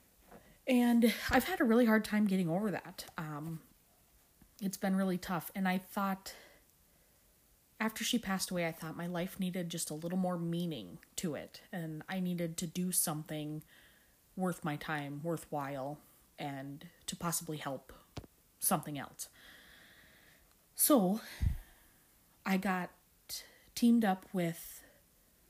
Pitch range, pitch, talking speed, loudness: 160-195 Hz, 180 Hz, 130 wpm, -35 LUFS